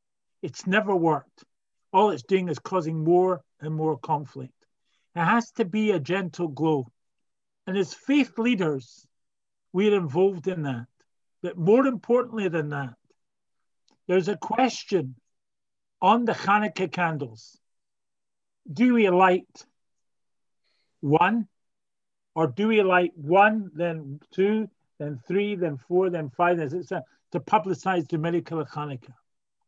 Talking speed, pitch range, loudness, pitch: 130 wpm, 155-205 Hz, -25 LUFS, 180 Hz